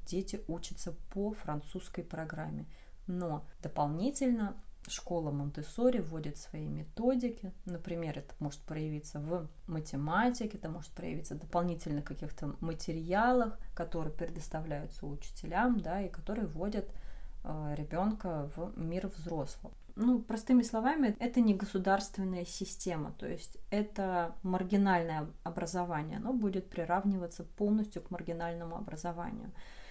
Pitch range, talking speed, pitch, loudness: 155-200 Hz, 110 wpm, 175 Hz, -36 LUFS